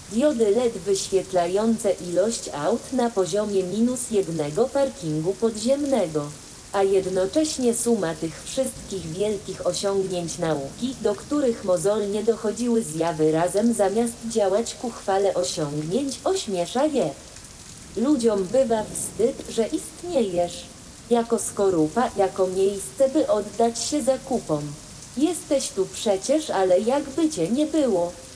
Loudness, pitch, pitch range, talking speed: -24 LUFS, 205 Hz, 185-245 Hz, 110 wpm